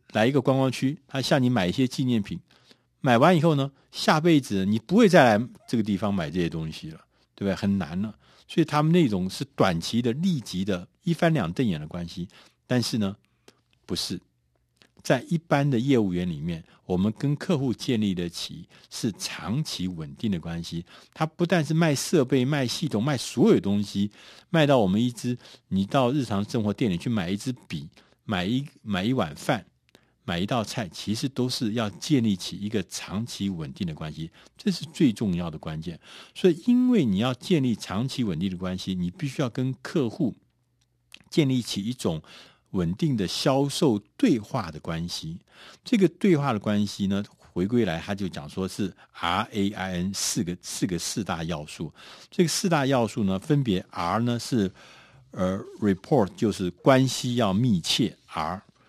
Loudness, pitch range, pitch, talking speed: -26 LUFS, 100-150 Hz, 120 Hz, 260 characters per minute